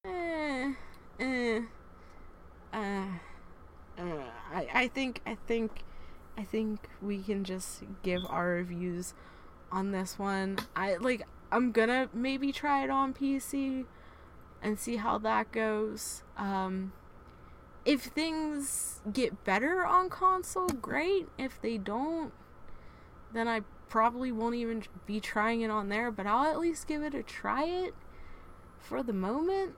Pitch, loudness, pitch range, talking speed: 225 Hz, -33 LUFS, 195-275 Hz, 135 wpm